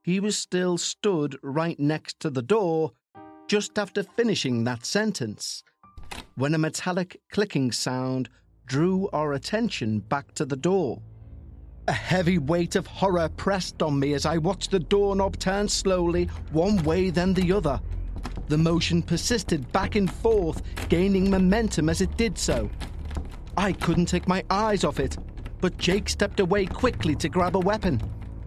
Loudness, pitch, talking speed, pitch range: -25 LUFS, 170 Hz, 155 wpm, 130-195 Hz